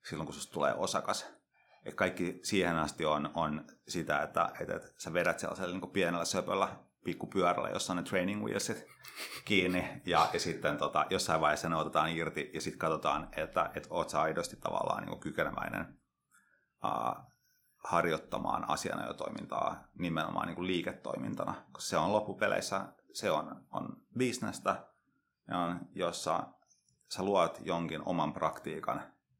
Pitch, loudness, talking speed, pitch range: 85 Hz, -35 LUFS, 145 wpm, 80-90 Hz